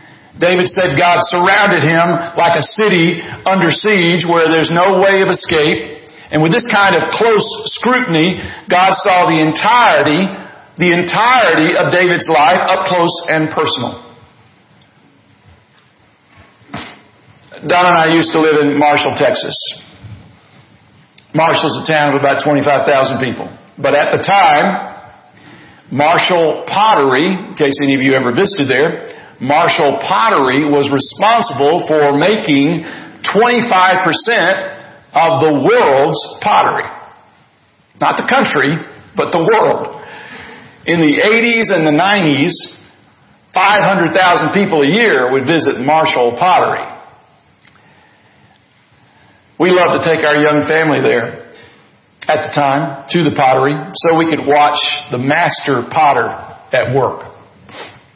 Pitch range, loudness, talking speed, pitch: 145-185 Hz, -11 LUFS, 125 wpm, 160 Hz